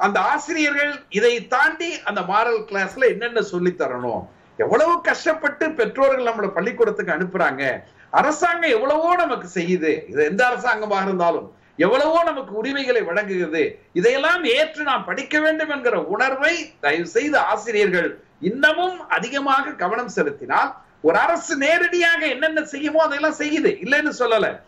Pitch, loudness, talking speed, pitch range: 285 Hz, -20 LUFS, 125 wpm, 220-325 Hz